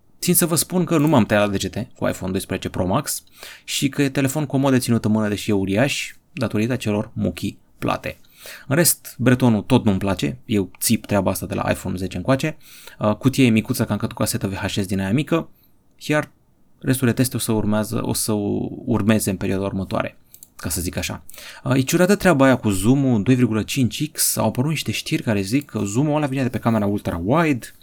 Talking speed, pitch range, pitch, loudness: 205 wpm, 105-135 Hz, 115 Hz, -20 LUFS